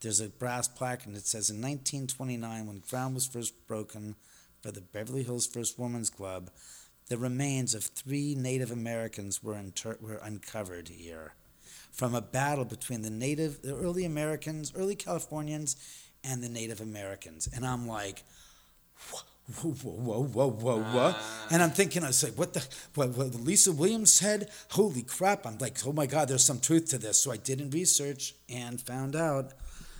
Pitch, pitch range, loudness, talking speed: 125 Hz, 110-145 Hz, -30 LUFS, 180 wpm